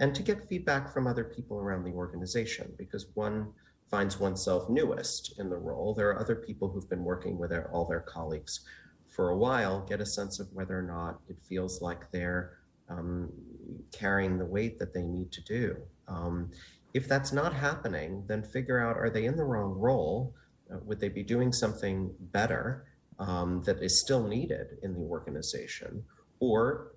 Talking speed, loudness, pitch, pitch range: 185 wpm, -33 LUFS, 100 Hz, 90-115 Hz